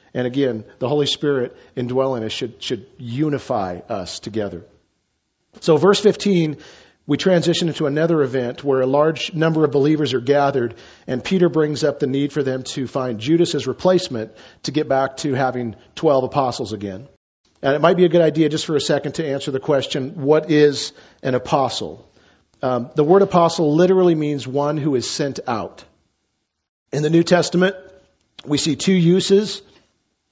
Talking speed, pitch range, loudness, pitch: 170 wpm, 130-160 Hz, -19 LUFS, 145 Hz